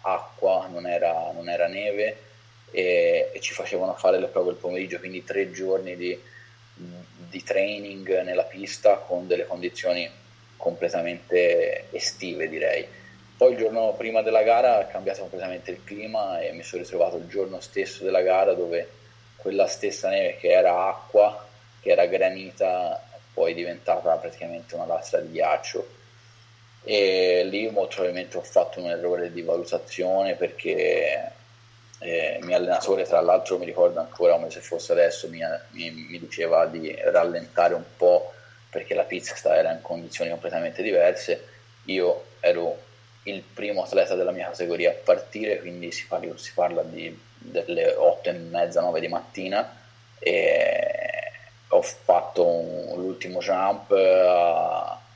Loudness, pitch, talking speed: -24 LUFS, 115 Hz, 150 wpm